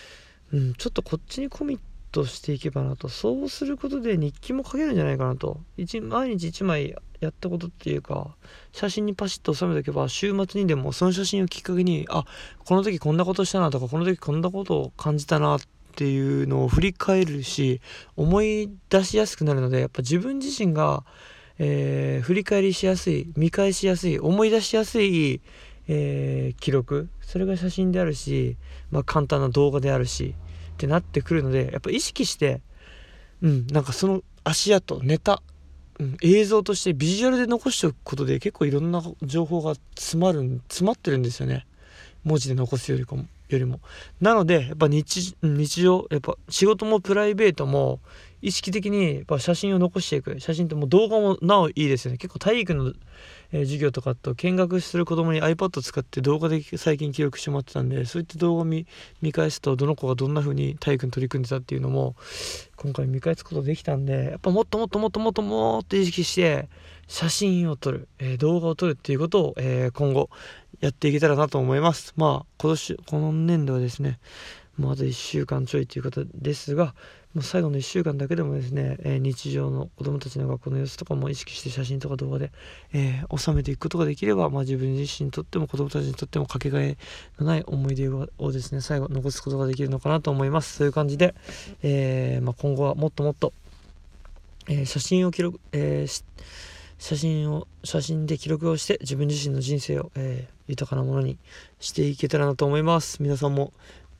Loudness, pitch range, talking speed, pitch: -25 LUFS, 135-180 Hz, 380 characters per minute, 150 Hz